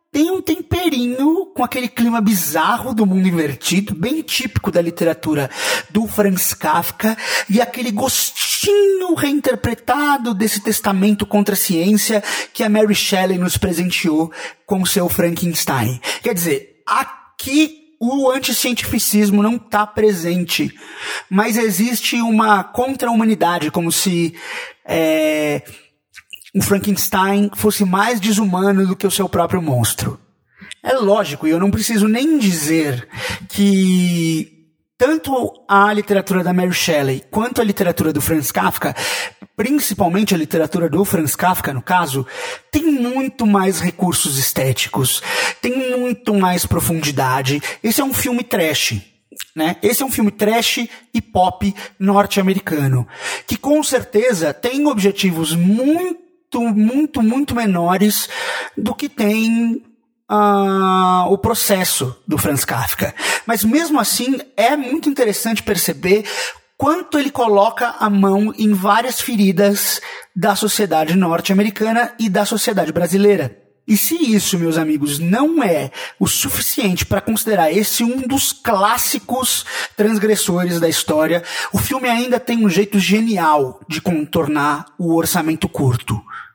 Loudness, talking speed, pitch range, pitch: -16 LUFS, 130 wpm, 170-235 Hz, 205 Hz